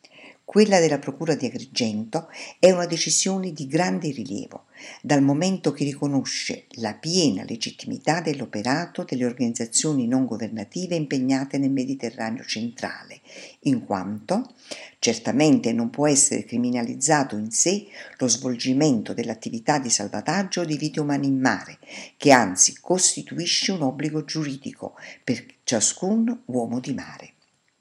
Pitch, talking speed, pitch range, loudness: 145 Hz, 125 wpm, 125-175 Hz, -23 LUFS